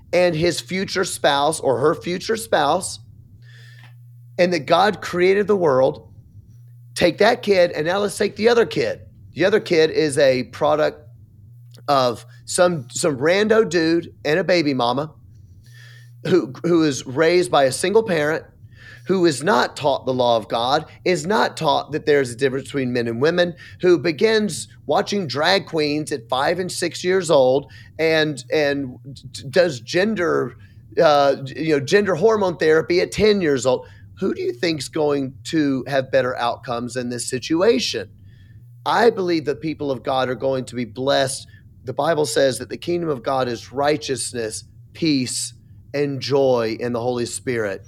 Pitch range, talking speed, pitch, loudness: 120-170 Hz, 165 wpm, 140 Hz, -20 LUFS